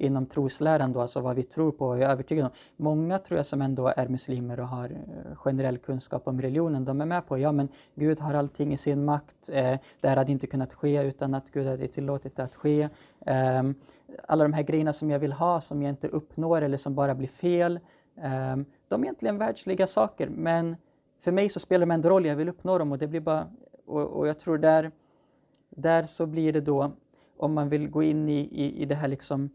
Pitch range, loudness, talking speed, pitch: 135-160 Hz, -27 LUFS, 220 wpm, 145 Hz